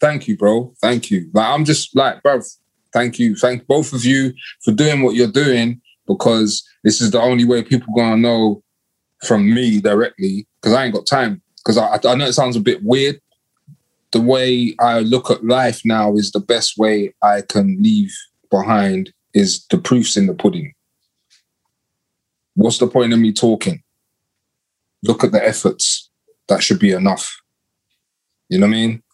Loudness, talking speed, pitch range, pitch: -16 LUFS, 180 wpm, 110-140 Hz, 120 Hz